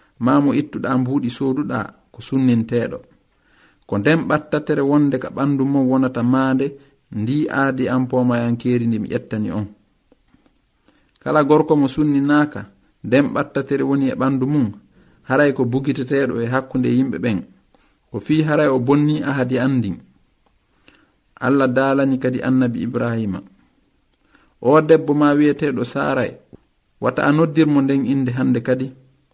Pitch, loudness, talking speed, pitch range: 135 Hz, -18 LUFS, 135 wpm, 125-145 Hz